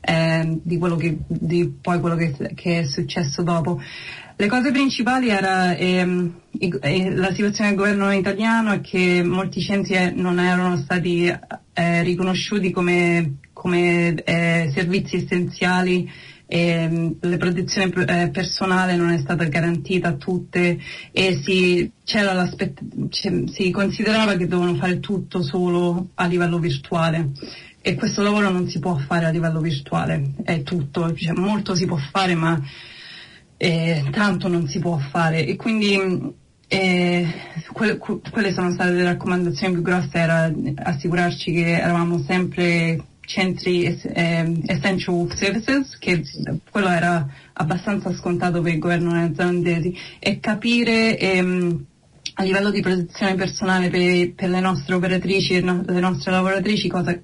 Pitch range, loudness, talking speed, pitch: 170-190 Hz, -20 LUFS, 145 wpm, 180 Hz